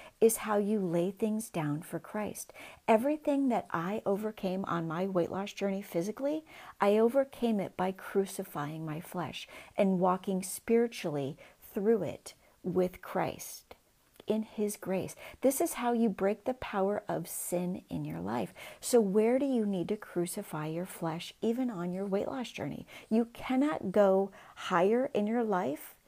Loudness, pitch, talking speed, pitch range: -32 LUFS, 200 Hz, 160 wpm, 180-230 Hz